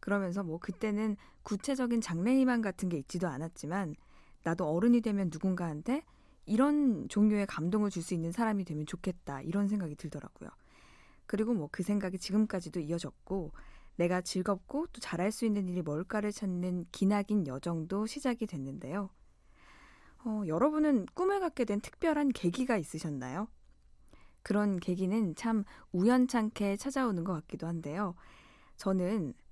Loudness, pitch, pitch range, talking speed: -33 LUFS, 195 Hz, 170-220 Hz, 325 characters per minute